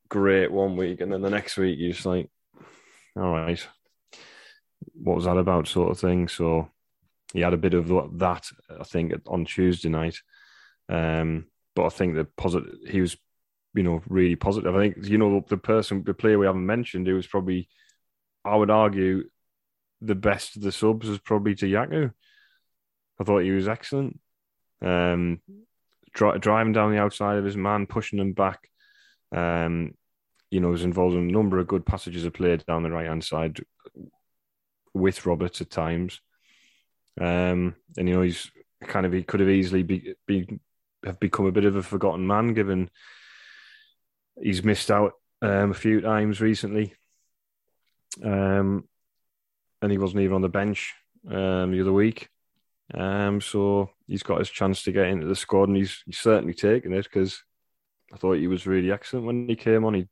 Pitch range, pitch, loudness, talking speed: 90-105 Hz, 95 Hz, -25 LUFS, 180 wpm